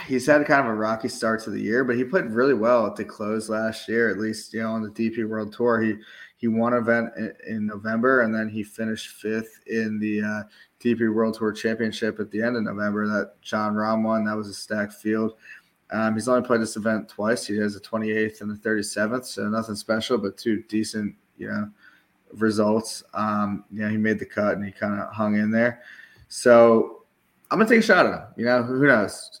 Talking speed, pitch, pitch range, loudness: 230 wpm, 110 Hz, 105-115 Hz, -24 LUFS